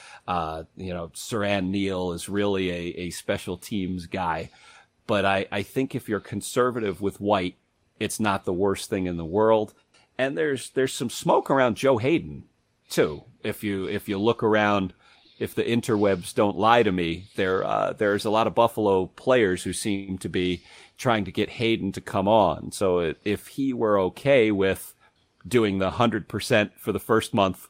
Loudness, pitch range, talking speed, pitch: -25 LUFS, 95-110 Hz, 180 wpm, 100 Hz